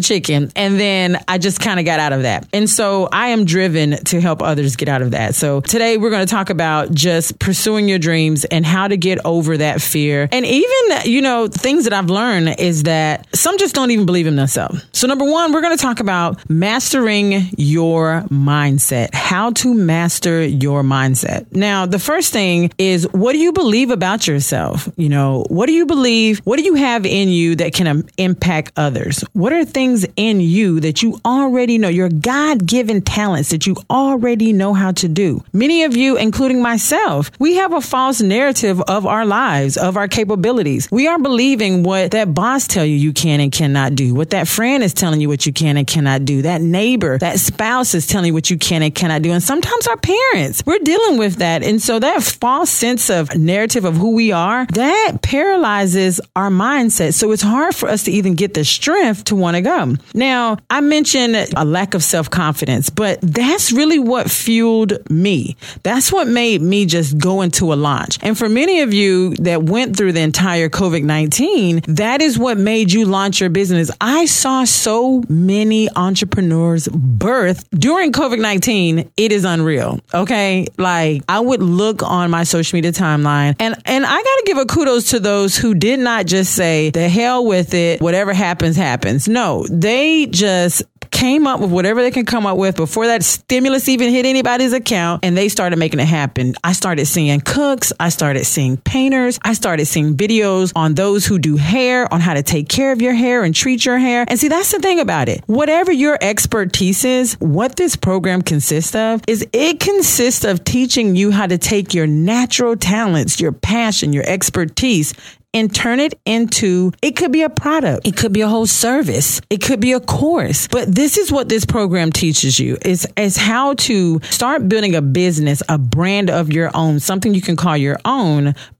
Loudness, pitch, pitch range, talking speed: -14 LUFS, 195 Hz, 165-240 Hz, 200 wpm